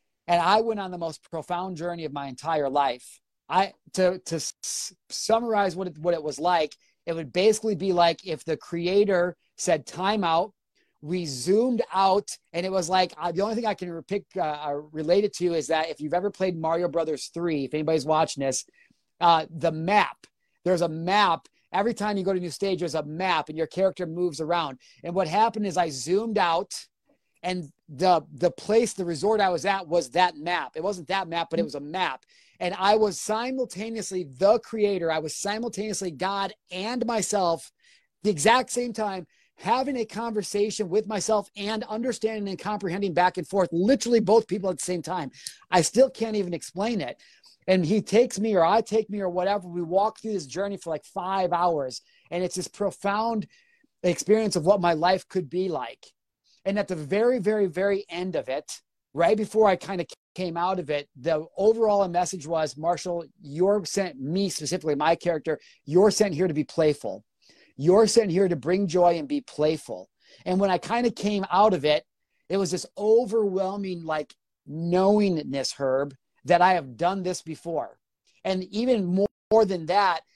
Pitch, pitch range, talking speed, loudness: 185 Hz, 170-205 Hz, 195 wpm, -25 LUFS